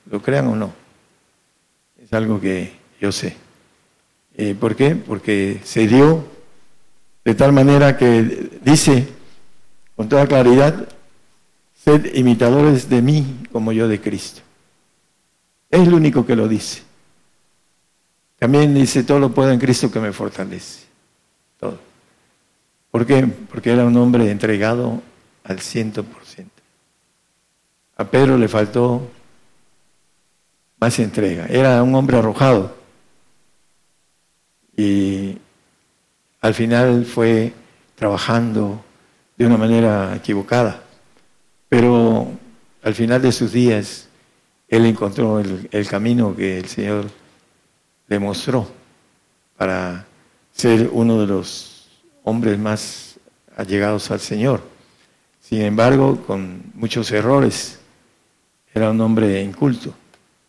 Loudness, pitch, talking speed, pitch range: -16 LUFS, 115 Hz, 110 wpm, 105-125 Hz